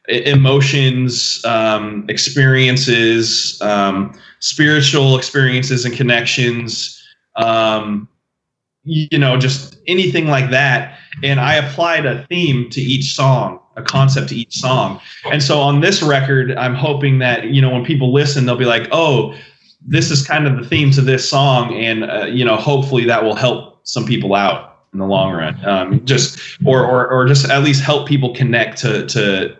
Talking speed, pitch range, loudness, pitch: 165 wpm, 125-145 Hz, -14 LUFS, 135 Hz